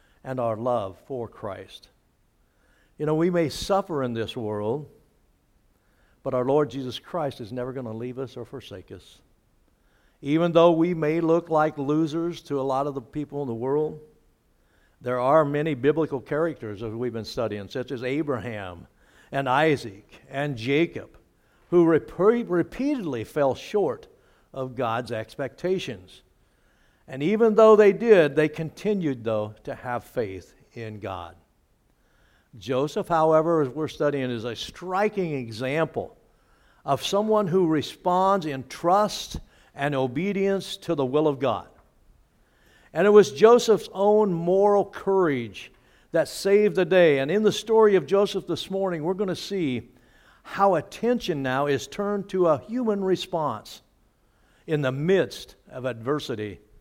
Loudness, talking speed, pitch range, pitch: -24 LUFS, 145 wpm, 125-185 Hz, 150 Hz